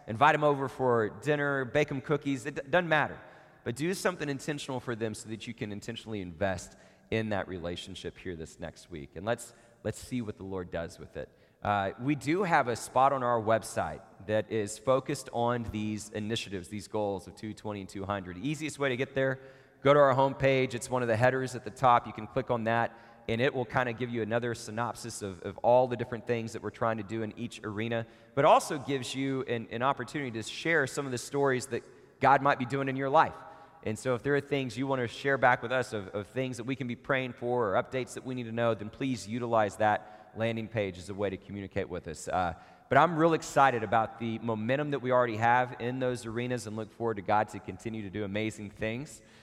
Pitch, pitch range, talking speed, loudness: 120 Hz, 105-135 Hz, 235 wpm, -31 LUFS